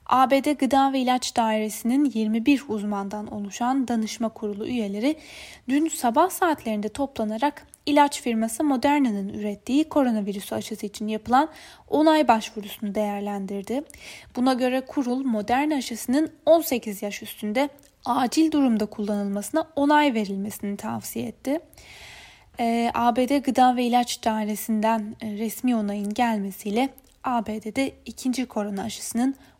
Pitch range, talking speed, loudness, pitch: 215-275 Hz, 105 wpm, -24 LUFS, 240 Hz